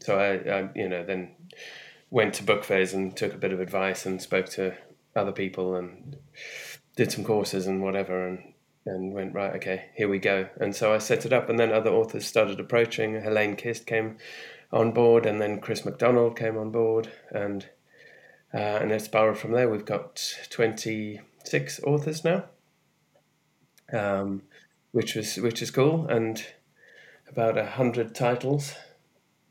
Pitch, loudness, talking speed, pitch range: 110 Hz, -27 LUFS, 165 wpm, 95-115 Hz